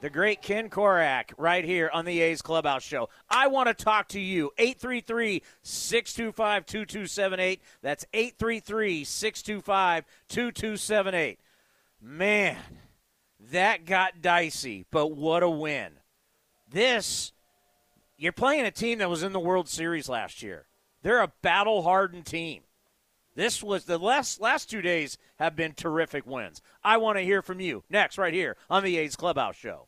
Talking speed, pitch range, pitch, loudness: 140 wpm, 165-215 Hz, 185 Hz, -27 LUFS